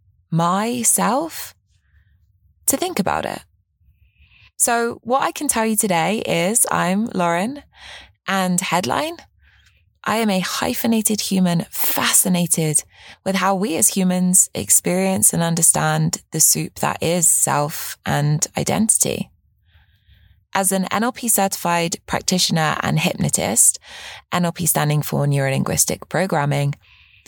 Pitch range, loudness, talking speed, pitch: 125-200 Hz, -18 LUFS, 110 wpm, 175 Hz